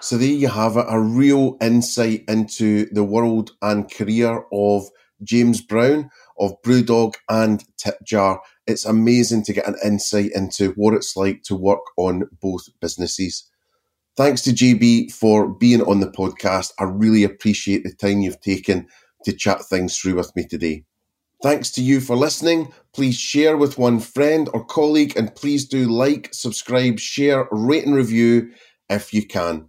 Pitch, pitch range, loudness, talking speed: 110 Hz, 100-125 Hz, -19 LUFS, 165 wpm